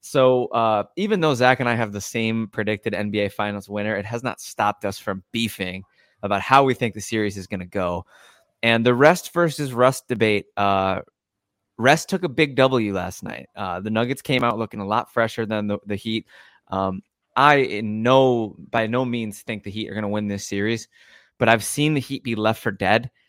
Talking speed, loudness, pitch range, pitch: 215 wpm, -22 LUFS, 100-125 Hz, 110 Hz